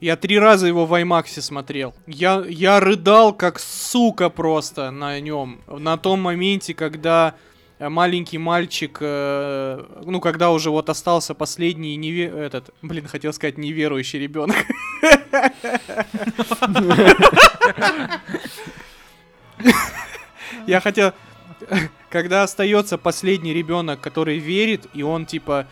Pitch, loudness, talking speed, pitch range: 170 Hz, -18 LUFS, 105 wpm, 150-195 Hz